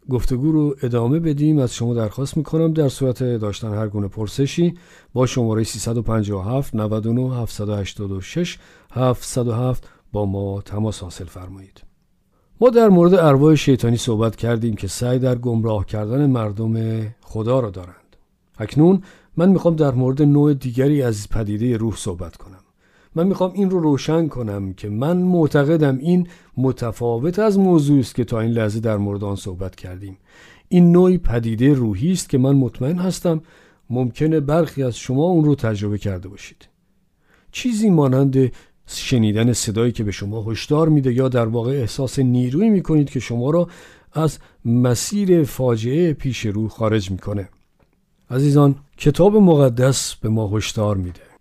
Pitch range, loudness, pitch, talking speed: 110-150 Hz, -19 LUFS, 125 Hz, 150 wpm